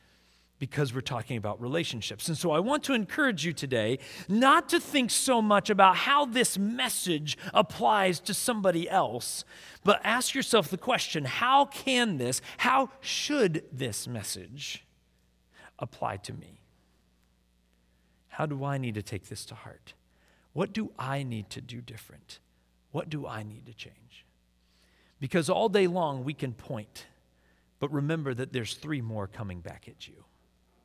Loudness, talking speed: -28 LUFS, 155 wpm